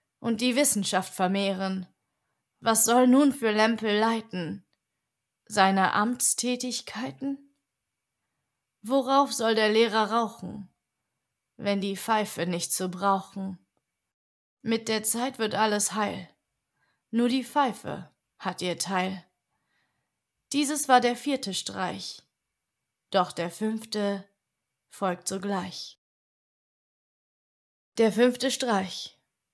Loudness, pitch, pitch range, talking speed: -26 LUFS, 215 Hz, 190-245 Hz, 100 wpm